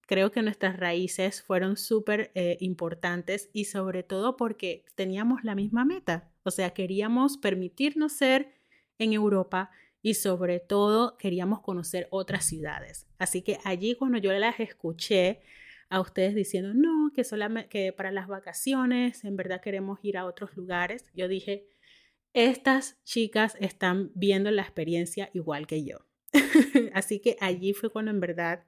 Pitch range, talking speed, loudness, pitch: 185-225 Hz, 150 wpm, -28 LUFS, 195 Hz